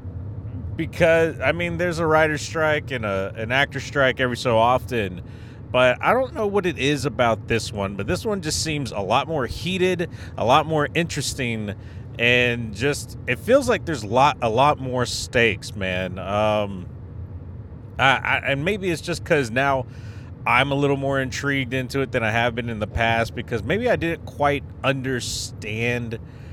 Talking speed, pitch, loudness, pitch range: 180 wpm, 125 Hz, -22 LUFS, 110-140 Hz